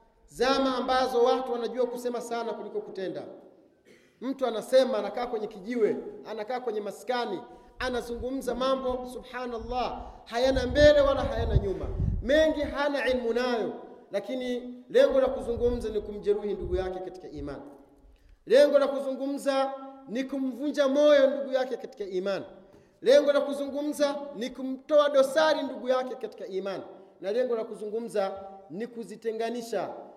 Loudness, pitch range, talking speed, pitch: -28 LUFS, 225-275 Hz, 125 wpm, 250 Hz